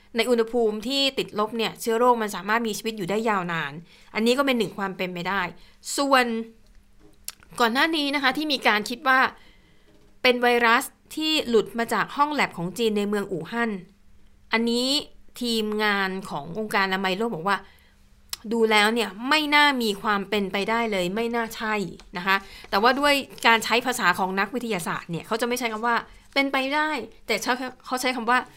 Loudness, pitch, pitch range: -23 LUFS, 225 Hz, 200-250 Hz